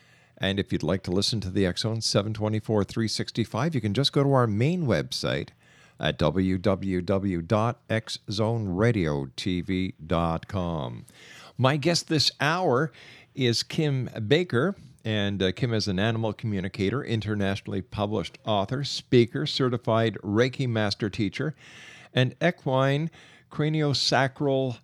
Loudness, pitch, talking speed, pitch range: -26 LUFS, 115 Hz, 110 wpm, 100-135 Hz